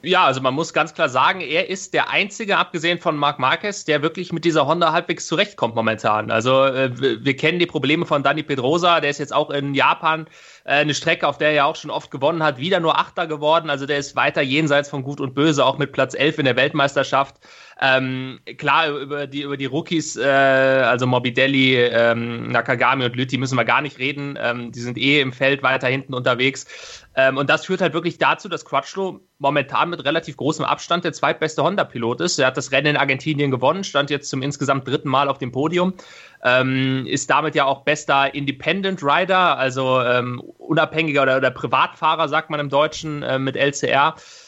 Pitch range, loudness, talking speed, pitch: 130-160 Hz, -19 LUFS, 205 wpm, 140 Hz